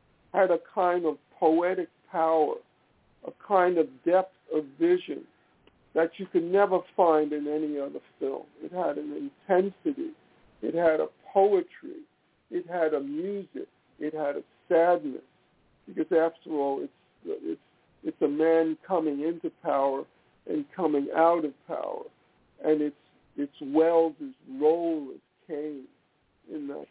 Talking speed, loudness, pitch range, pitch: 140 wpm, -28 LUFS, 155-200 Hz, 165 Hz